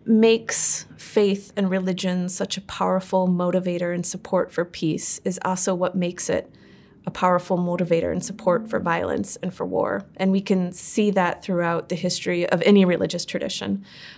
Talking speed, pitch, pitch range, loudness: 165 wpm, 180 Hz, 175-195 Hz, -23 LUFS